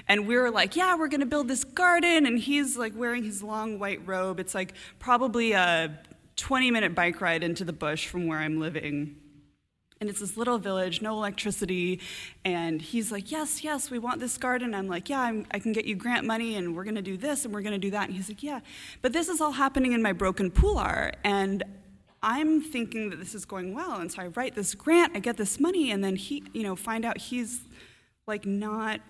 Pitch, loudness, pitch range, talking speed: 215 Hz, -28 LUFS, 190-250 Hz, 235 wpm